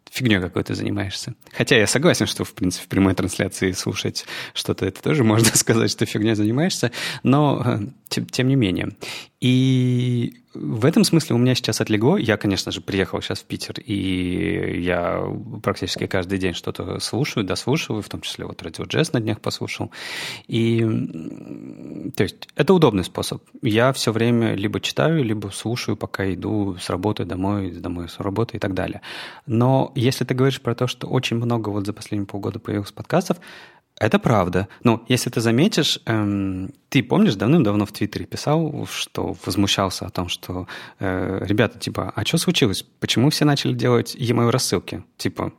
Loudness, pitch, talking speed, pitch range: -21 LUFS, 110 Hz, 170 wpm, 95-125 Hz